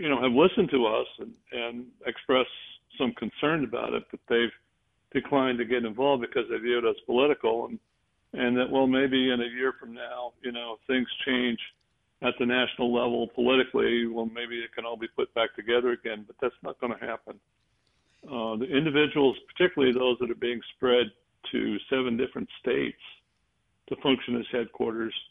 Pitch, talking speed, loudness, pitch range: 125 Hz, 185 wpm, -28 LUFS, 120-130 Hz